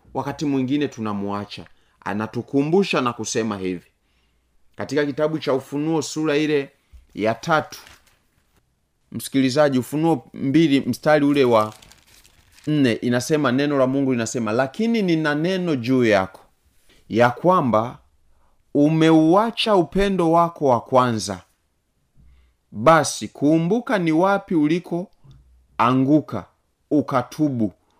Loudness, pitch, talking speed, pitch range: -20 LUFS, 135 Hz, 100 wpm, 105-155 Hz